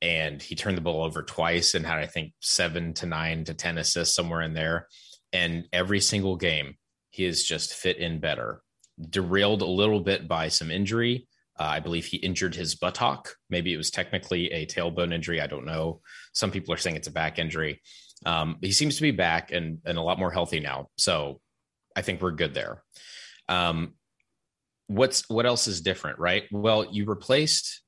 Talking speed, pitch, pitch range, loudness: 195 wpm, 85 Hz, 80-100 Hz, -27 LUFS